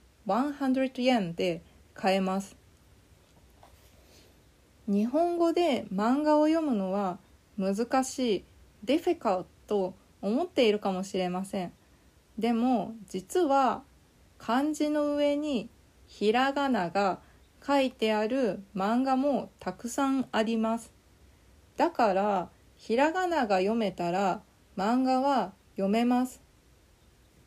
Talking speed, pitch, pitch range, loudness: 200 characters per minute, 225 Hz, 190-265 Hz, -29 LUFS